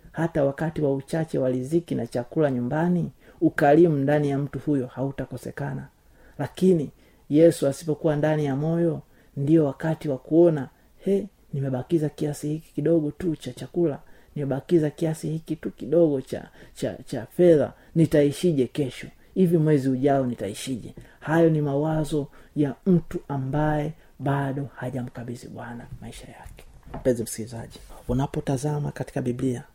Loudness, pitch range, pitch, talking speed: -25 LUFS, 130-160 Hz, 145 Hz, 125 wpm